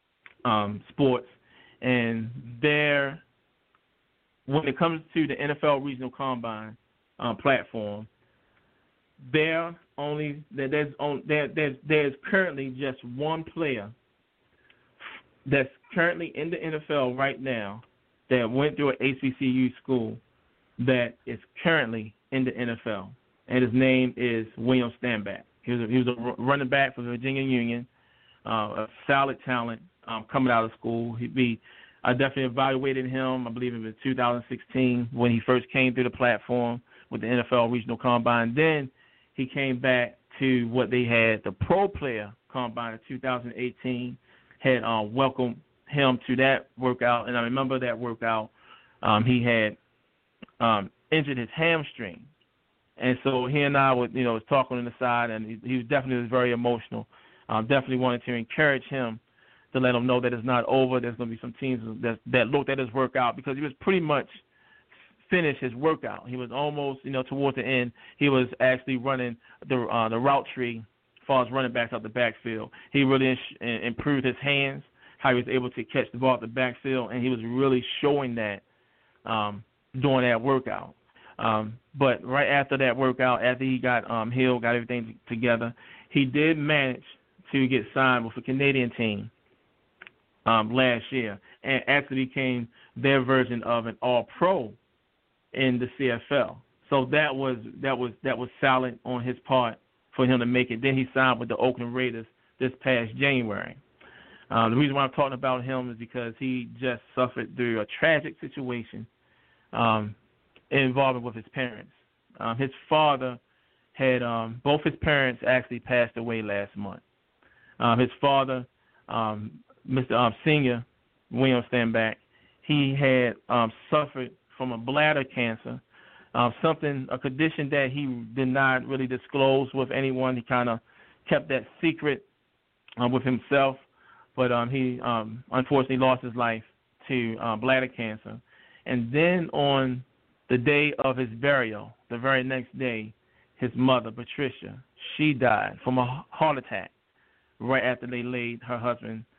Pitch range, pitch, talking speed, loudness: 120-135 Hz, 125 Hz, 165 wpm, -26 LUFS